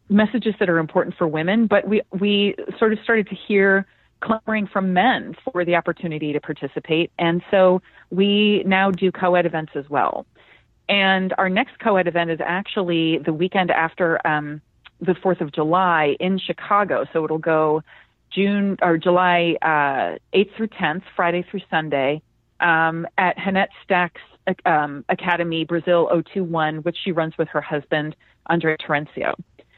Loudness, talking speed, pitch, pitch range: -20 LUFS, 155 wpm, 175 Hz, 160-195 Hz